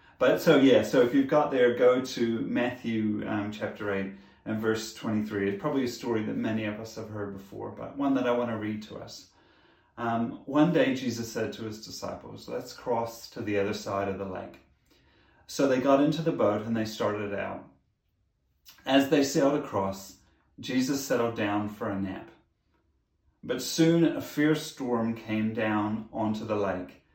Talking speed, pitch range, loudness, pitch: 185 wpm, 105-130 Hz, -28 LUFS, 110 Hz